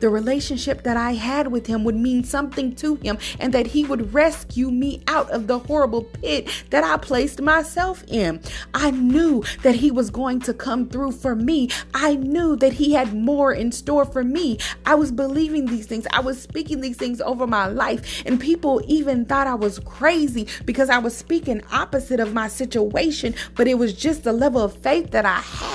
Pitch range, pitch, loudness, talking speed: 240-290 Hz, 260 Hz, -21 LUFS, 205 wpm